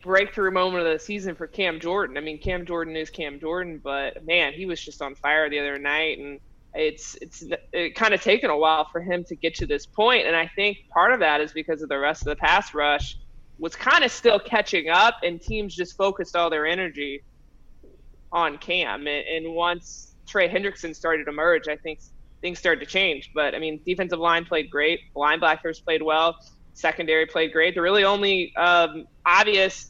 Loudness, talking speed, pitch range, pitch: -23 LUFS, 205 wpm, 155-185 Hz, 165 Hz